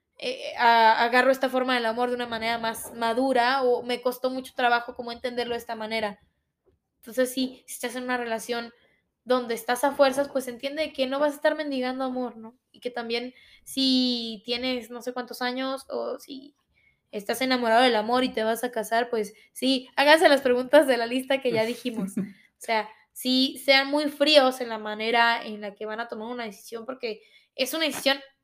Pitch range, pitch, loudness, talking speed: 230-265 Hz, 250 Hz, -25 LUFS, 200 wpm